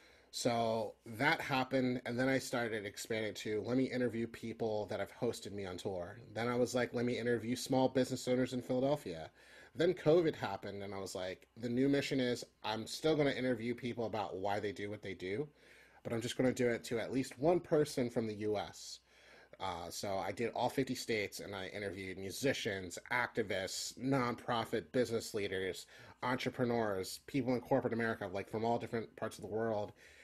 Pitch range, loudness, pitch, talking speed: 105-130 Hz, -37 LUFS, 120 Hz, 190 wpm